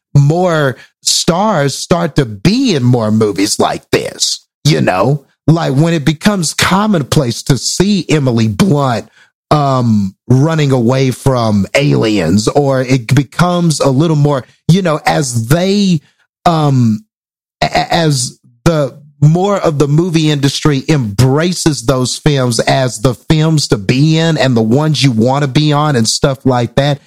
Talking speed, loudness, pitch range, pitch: 145 wpm, -12 LUFS, 125-160 Hz, 145 Hz